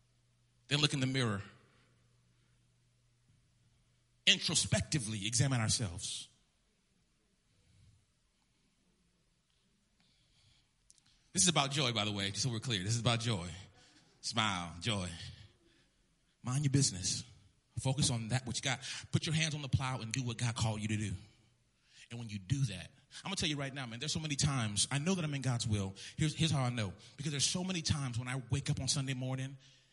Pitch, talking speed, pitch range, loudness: 120 Hz, 175 wpm, 110-140 Hz, -35 LUFS